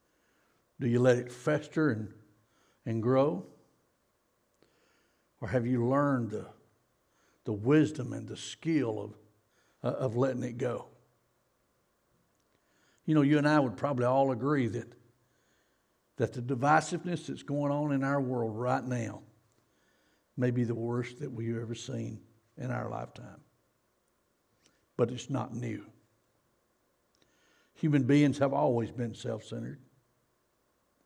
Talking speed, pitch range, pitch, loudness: 130 wpm, 115-140 Hz, 125 Hz, -31 LUFS